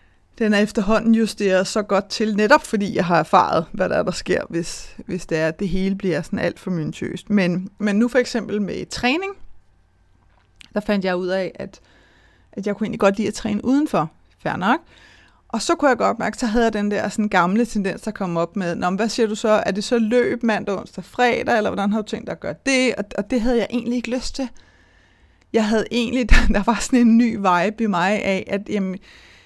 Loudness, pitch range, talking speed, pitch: -20 LUFS, 185-230 Hz, 230 wpm, 210 Hz